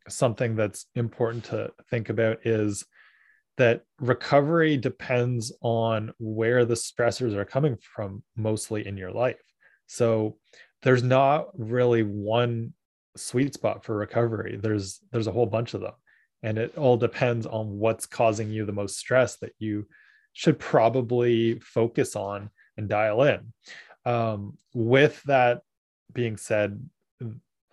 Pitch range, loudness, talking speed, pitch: 110-125 Hz, -26 LUFS, 135 wpm, 115 Hz